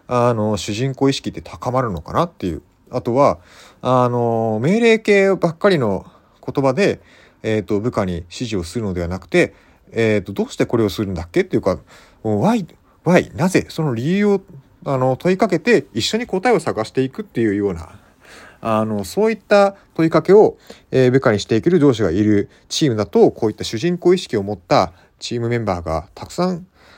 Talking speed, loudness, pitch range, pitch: 325 characters per minute, -18 LUFS, 105-175 Hz, 125 Hz